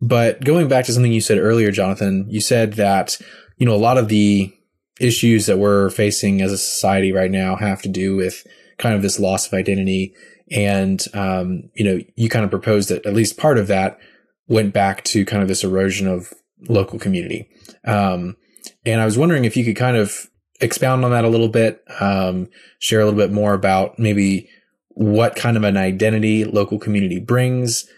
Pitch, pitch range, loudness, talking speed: 105 Hz, 95-115 Hz, -17 LUFS, 200 wpm